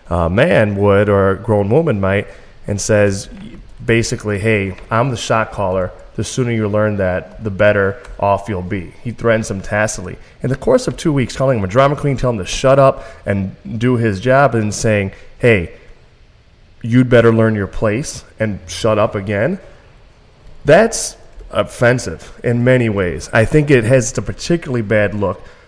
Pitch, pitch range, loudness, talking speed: 110 Hz, 100-125 Hz, -15 LUFS, 175 wpm